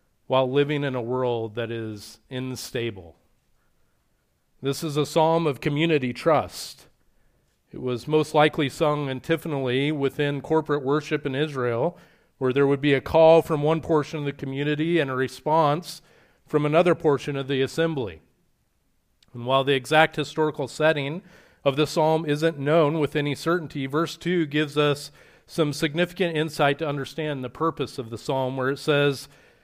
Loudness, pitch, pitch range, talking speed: -24 LUFS, 145 Hz, 135-155 Hz, 160 wpm